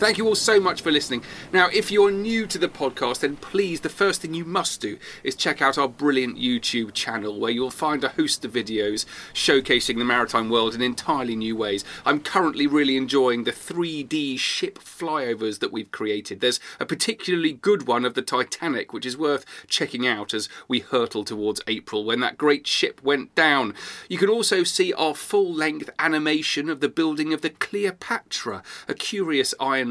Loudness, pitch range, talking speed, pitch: -23 LUFS, 125-200 Hz, 195 wpm, 145 Hz